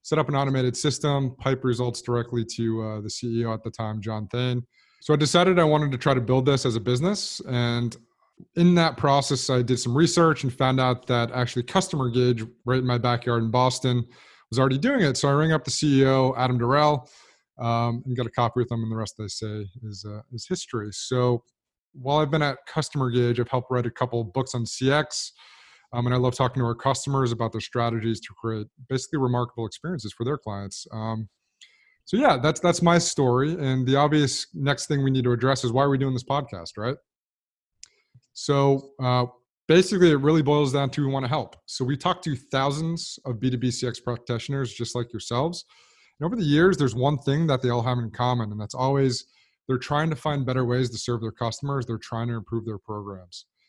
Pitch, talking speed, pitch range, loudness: 125 Hz, 215 wpm, 120-140 Hz, -24 LUFS